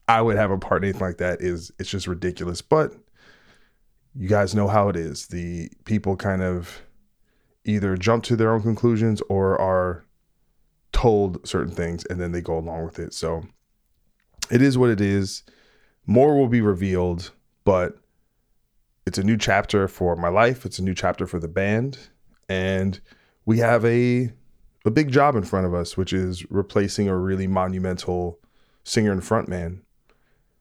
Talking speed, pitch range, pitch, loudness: 170 wpm, 90-110 Hz, 95 Hz, -23 LUFS